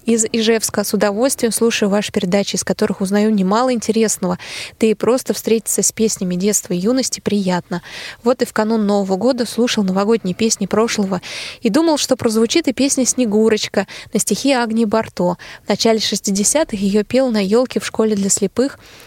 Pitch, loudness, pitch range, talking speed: 220 Hz, -17 LUFS, 205-235 Hz, 170 wpm